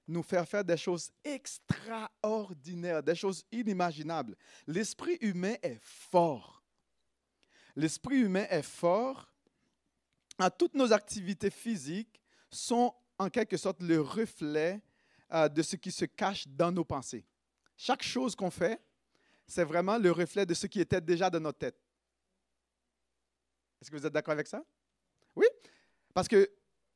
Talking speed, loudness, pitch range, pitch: 135 wpm, -33 LUFS, 165-215 Hz, 185 Hz